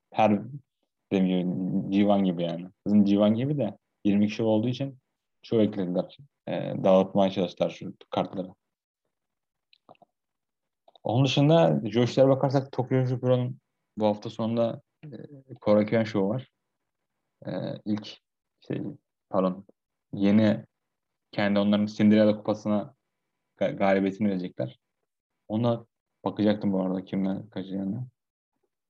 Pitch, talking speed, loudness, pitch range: 105 Hz, 105 wpm, -26 LUFS, 95-120 Hz